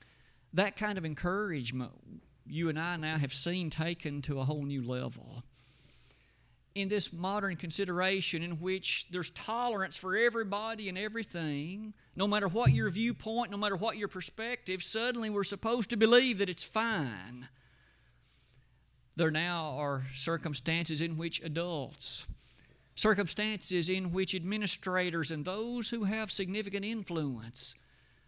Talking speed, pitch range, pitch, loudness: 135 wpm, 150-210 Hz, 180 Hz, -33 LUFS